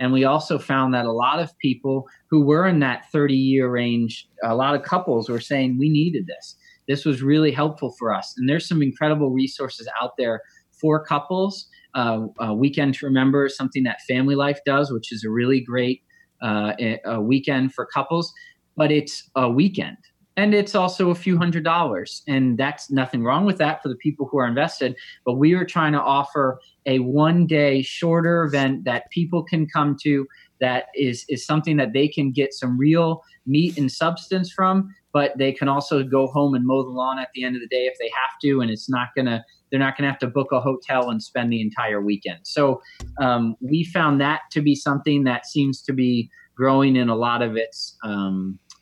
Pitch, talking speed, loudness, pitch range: 140 Hz, 210 wpm, -21 LUFS, 125-155 Hz